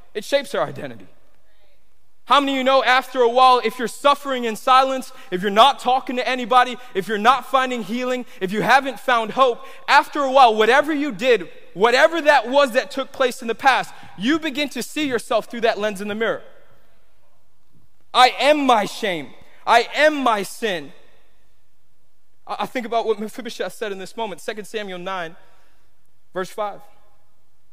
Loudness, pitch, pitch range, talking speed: -19 LUFS, 245 Hz, 210-265 Hz, 175 wpm